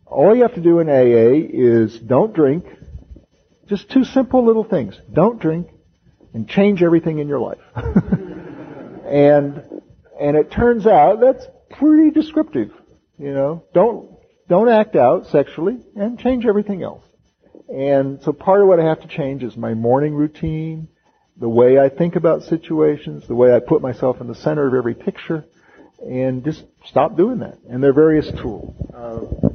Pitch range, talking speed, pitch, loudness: 135-200 Hz, 165 wpm, 155 Hz, -16 LUFS